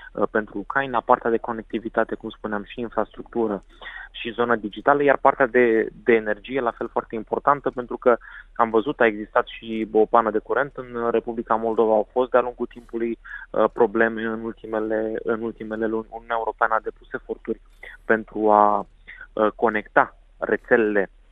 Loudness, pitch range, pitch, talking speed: -23 LUFS, 110-120 Hz, 115 Hz, 155 wpm